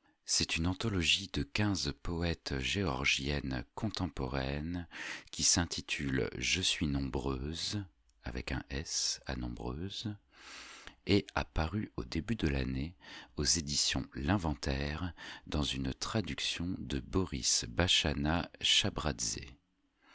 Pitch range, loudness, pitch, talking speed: 70-90 Hz, -33 LUFS, 75 Hz, 100 wpm